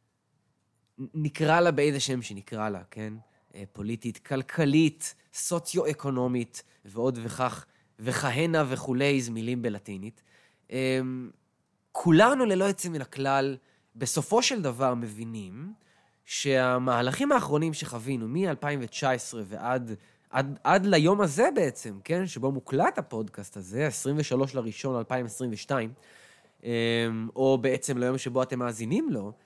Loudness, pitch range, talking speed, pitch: -28 LUFS, 115-150 Hz, 100 wpm, 130 Hz